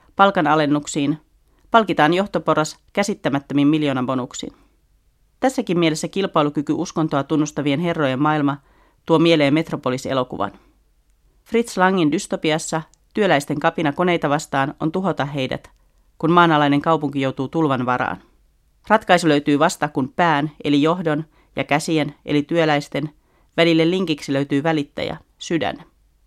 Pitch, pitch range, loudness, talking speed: 155 Hz, 145-165 Hz, -19 LUFS, 110 wpm